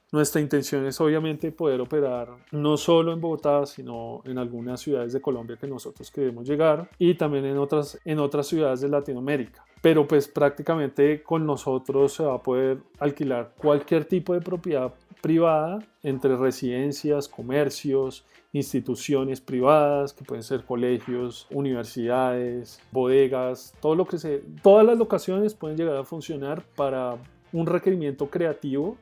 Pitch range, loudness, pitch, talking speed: 130-155 Hz, -25 LUFS, 145 Hz, 145 wpm